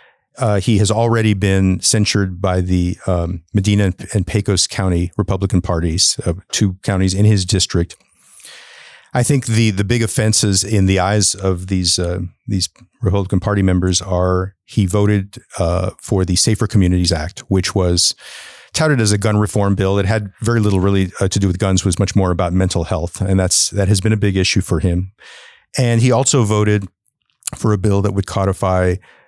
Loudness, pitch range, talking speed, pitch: -16 LUFS, 95-105 Hz, 190 wpm, 100 Hz